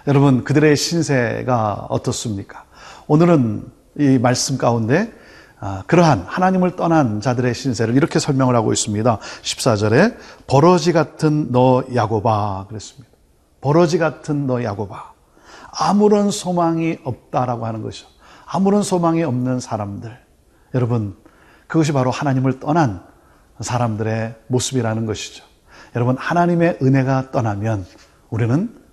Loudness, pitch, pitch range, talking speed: -18 LUFS, 125 Hz, 110-155 Hz, 295 characters per minute